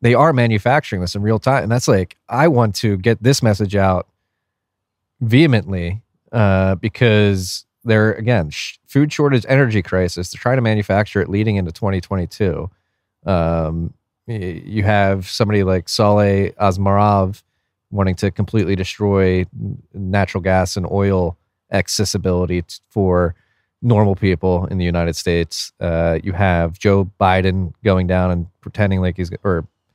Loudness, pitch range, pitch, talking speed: -17 LUFS, 90-110 Hz, 100 Hz, 140 wpm